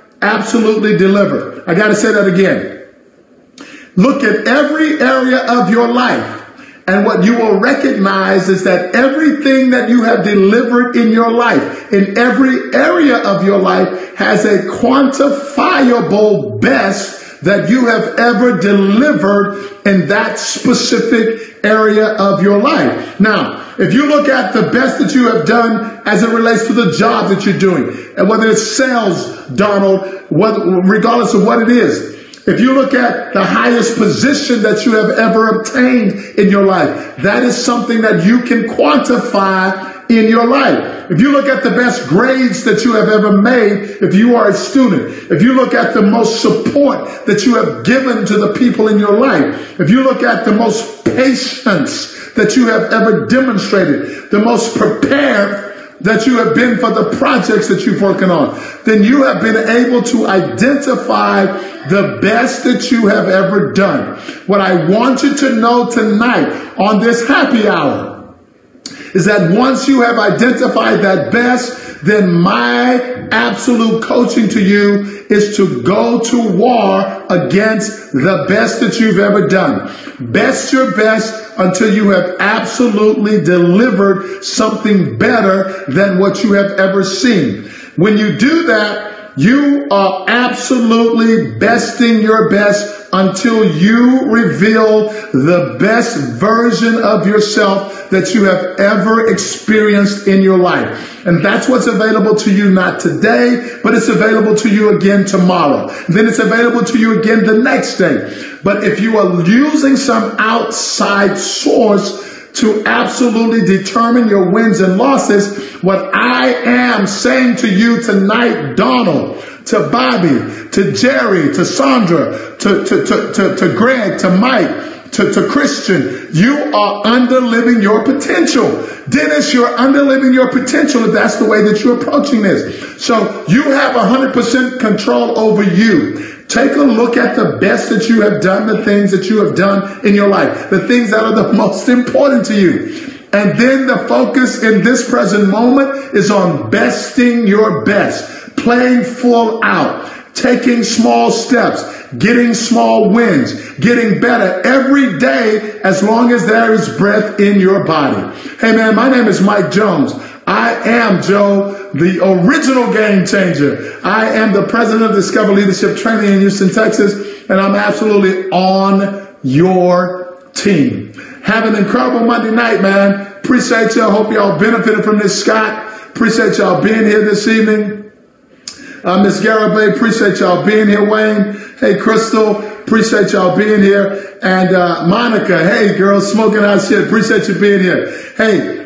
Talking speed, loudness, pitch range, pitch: 155 wpm, -11 LUFS, 200-240 Hz, 220 Hz